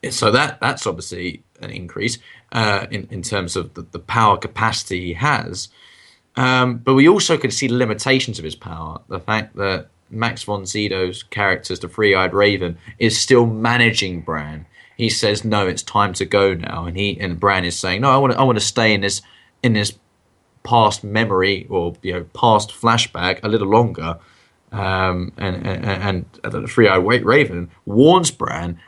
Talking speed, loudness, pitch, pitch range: 185 wpm, -18 LUFS, 100 Hz, 90-115 Hz